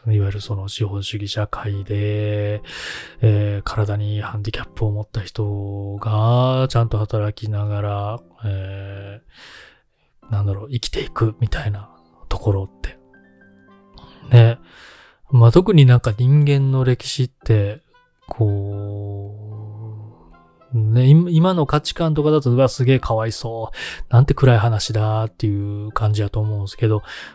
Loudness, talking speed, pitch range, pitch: -19 LUFS, 265 characters per minute, 100-120 Hz, 105 Hz